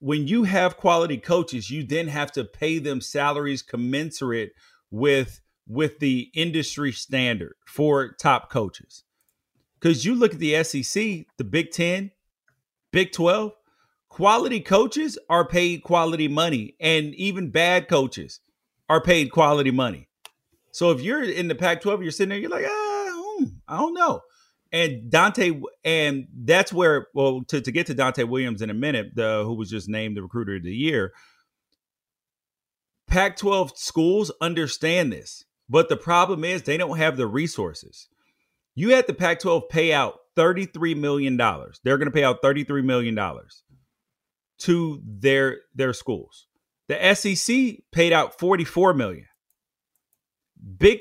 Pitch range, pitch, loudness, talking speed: 135-180 Hz, 160 Hz, -22 LUFS, 150 wpm